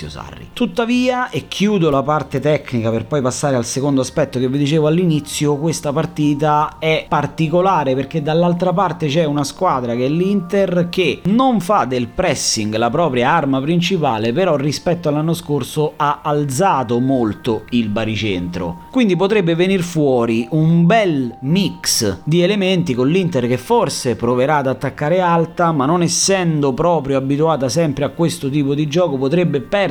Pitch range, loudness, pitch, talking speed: 135-175 Hz, -16 LUFS, 150 Hz, 155 wpm